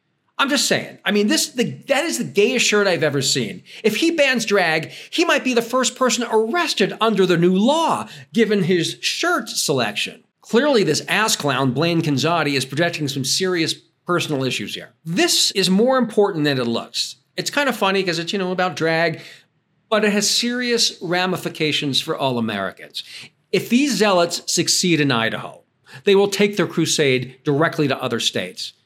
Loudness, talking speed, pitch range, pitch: -19 LUFS, 180 wpm, 155-225 Hz, 180 Hz